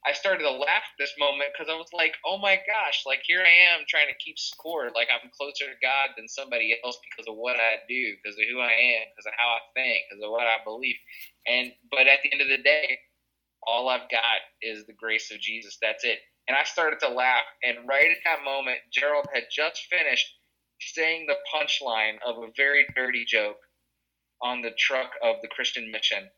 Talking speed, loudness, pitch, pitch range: 220 wpm, -24 LUFS, 130 Hz, 115-145 Hz